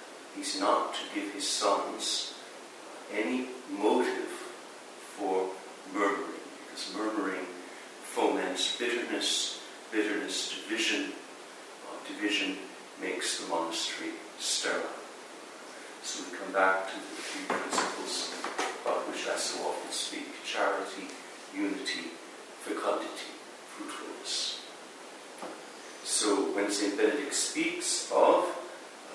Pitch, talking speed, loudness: 125 Hz, 95 wpm, -31 LUFS